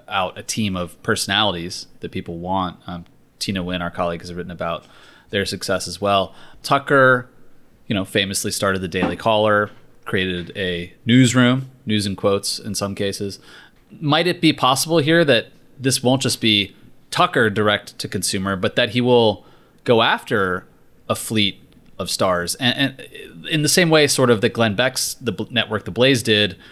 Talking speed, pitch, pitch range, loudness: 175 wpm, 105 Hz, 95-125 Hz, -19 LUFS